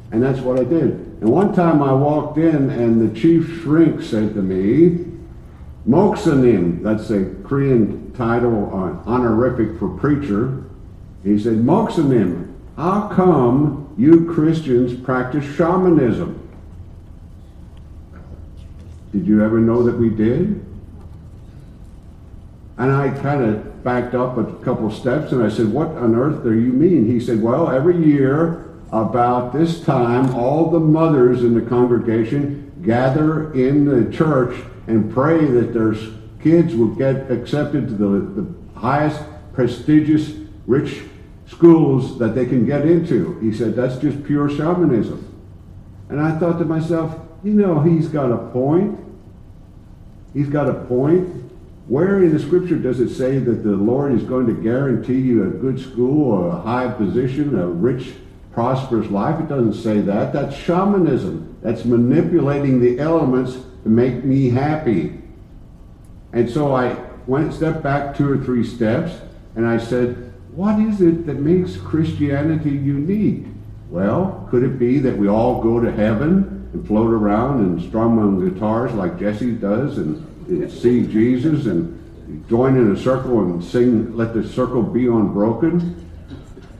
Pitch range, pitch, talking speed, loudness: 110-150 Hz, 125 Hz, 150 wpm, -17 LUFS